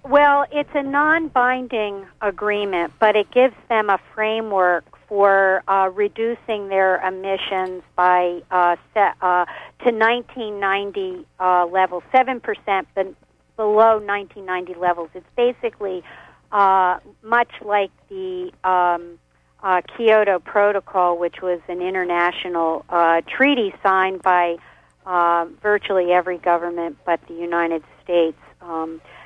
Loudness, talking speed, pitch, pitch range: -20 LUFS, 120 wpm, 195 Hz, 180-220 Hz